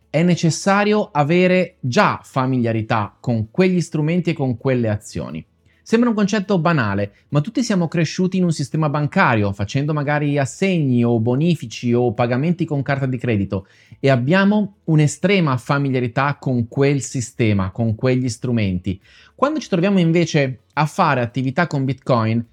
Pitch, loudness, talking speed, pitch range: 140 Hz, -19 LUFS, 145 wpm, 120-175 Hz